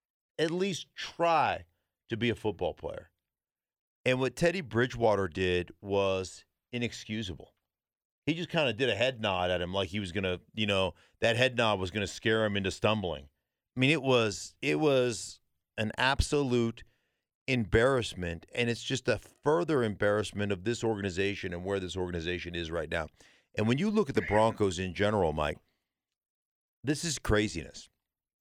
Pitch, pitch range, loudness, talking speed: 110 Hz, 95-125 Hz, -30 LUFS, 170 wpm